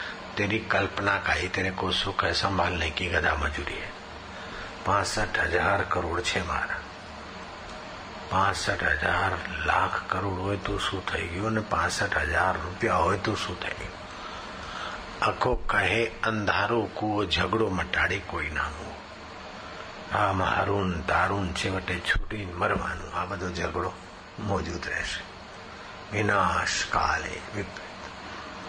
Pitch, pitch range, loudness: 95 Hz, 90-100 Hz, -27 LUFS